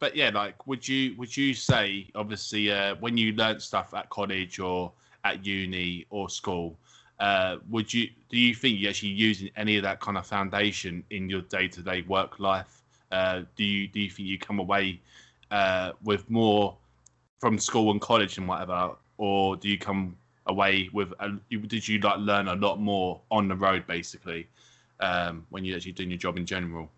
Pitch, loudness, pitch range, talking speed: 100 Hz, -28 LUFS, 90-105 Hz, 200 wpm